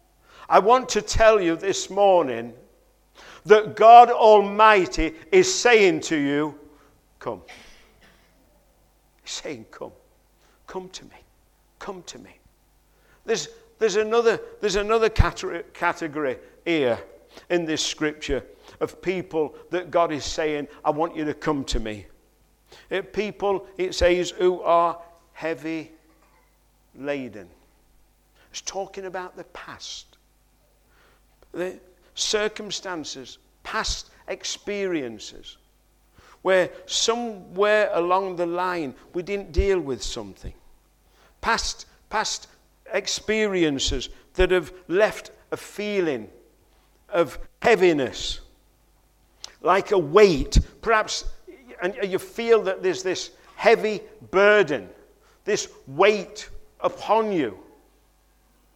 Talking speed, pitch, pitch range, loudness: 100 wpm, 185 Hz, 160-215 Hz, -22 LUFS